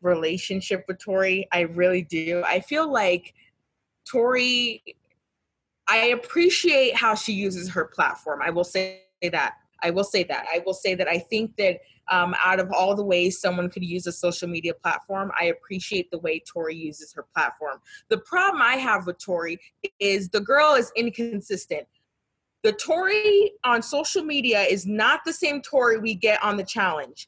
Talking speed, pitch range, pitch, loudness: 175 wpm, 180-245 Hz, 195 Hz, -23 LUFS